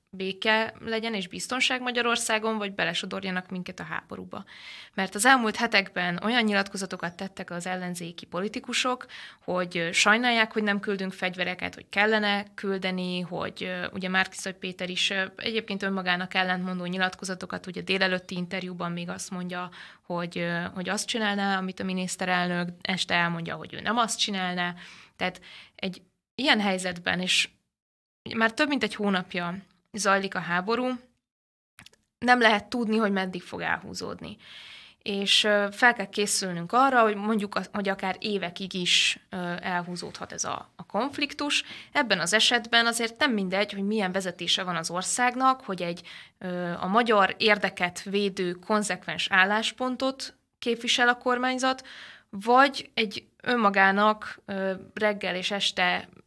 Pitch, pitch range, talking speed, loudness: 195 Hz, 185-220 Hz, 130 wpm, -26 LUFS